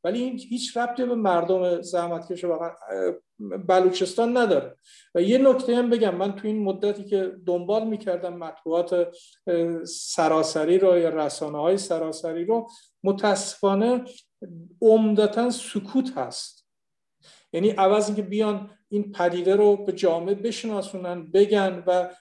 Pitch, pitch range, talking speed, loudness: 195 Hz, 175-215 Hz, 125 wpm, -24 LUFS